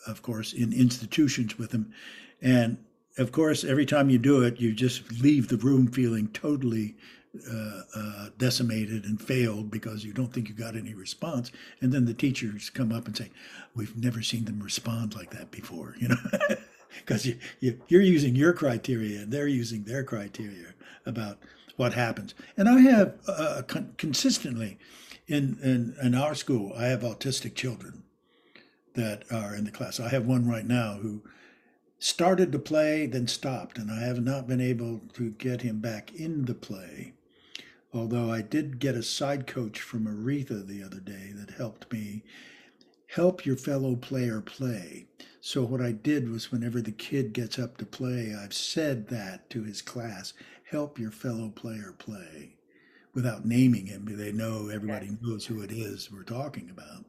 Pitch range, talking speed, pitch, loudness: 110-130 Hz, 175 wpm, 120 Hz, -28 LUFS